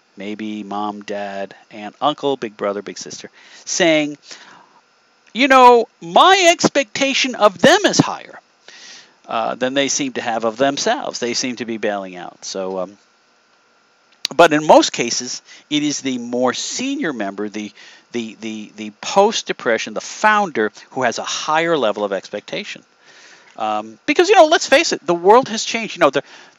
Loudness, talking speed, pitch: -17 LUFS, 160 wpm, 125 Hz